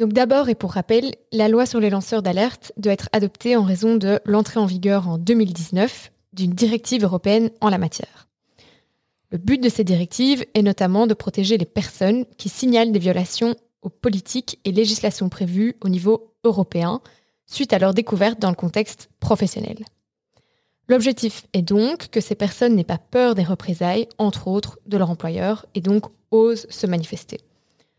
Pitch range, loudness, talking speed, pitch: 195-230 Hz, -20 LUFS, 170 wpm, 210 Hz